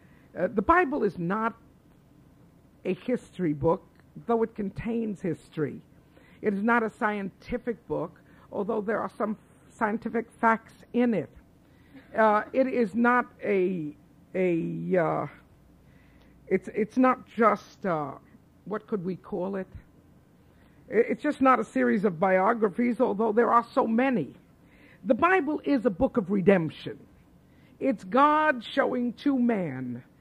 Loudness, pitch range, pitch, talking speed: -27 LUFS, 190-245 Hz, 225 Hz, 135 wpm